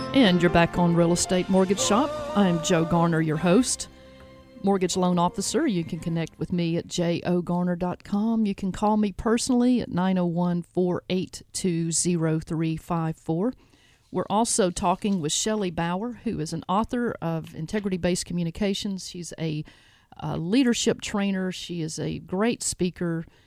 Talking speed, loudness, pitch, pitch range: 145 wpm, -25 LUFS, 180 Hz, 170-200 Hz